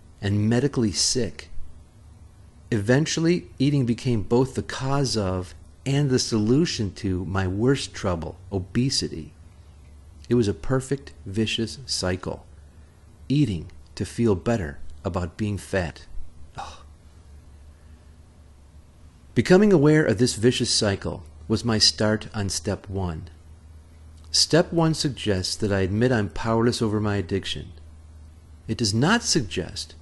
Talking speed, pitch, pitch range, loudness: 120 wpm, 95 Hz, 80-115 Hz, -23 LUFS